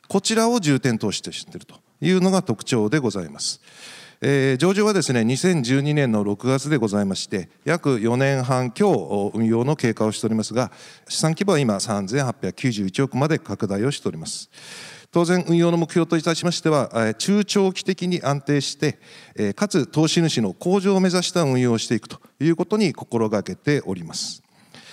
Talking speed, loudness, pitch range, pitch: 330 characters per minute, -21 LUFS, 115-175 Hz, 140 Hz